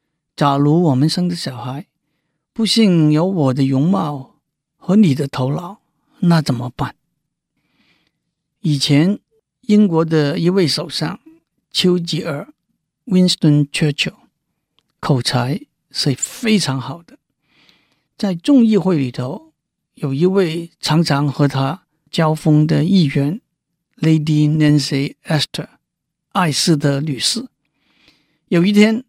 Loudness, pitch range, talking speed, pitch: -16 LUFS, 145-185 Hz, 205 characters per minute, 160 Hz